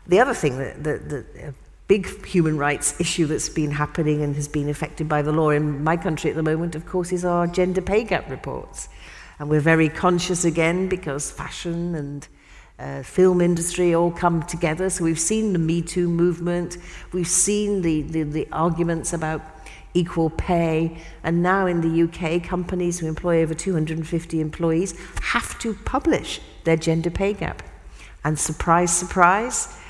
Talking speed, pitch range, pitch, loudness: 175 wpm, 155-180 Hz, 170 Hz, -22 LUFS